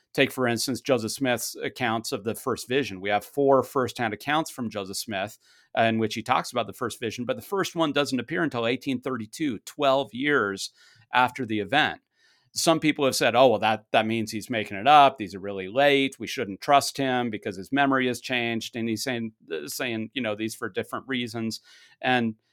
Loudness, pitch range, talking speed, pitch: -25 LUFS, 110-135 Hz, 200 wpm, 125 Hz